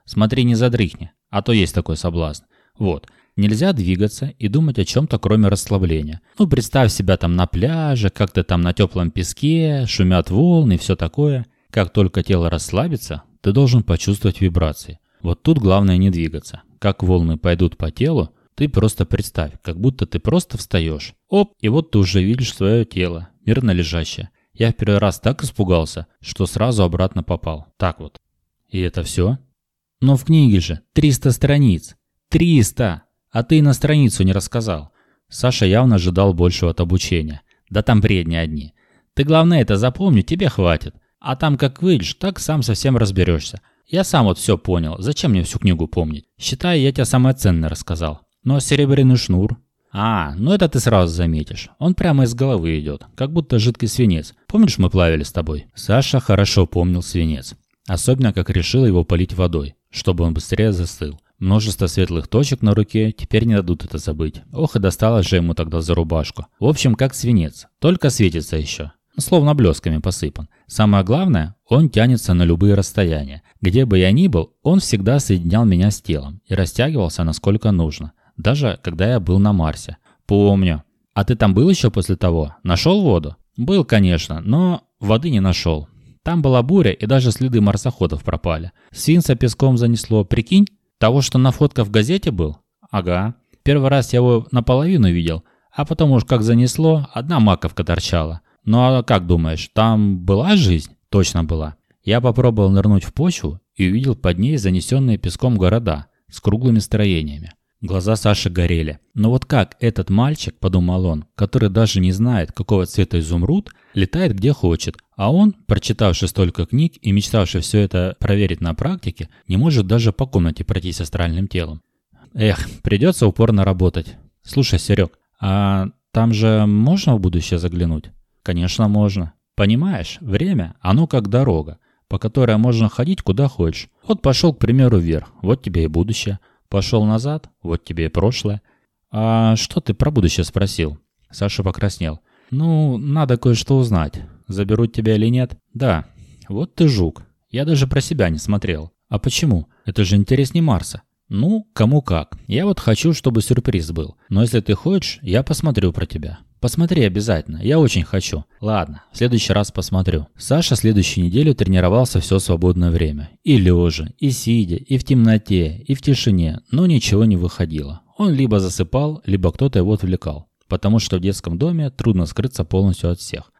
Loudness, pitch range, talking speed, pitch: -17 LUFS, 90-125 Hz, 170 wpm, 105 Hz